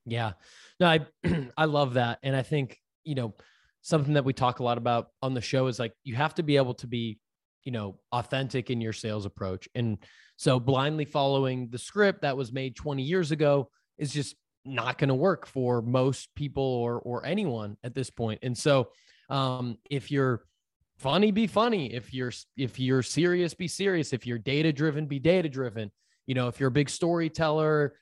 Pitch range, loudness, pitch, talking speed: 120-150 Hz, -28 LUFS, 135 Hz, 200 wpm